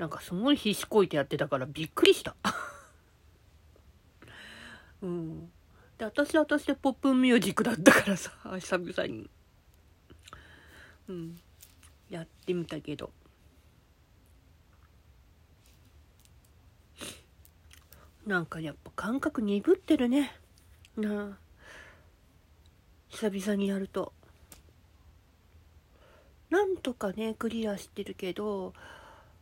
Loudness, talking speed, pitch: -30 LUFS, 190 characters per minute, 145 Hz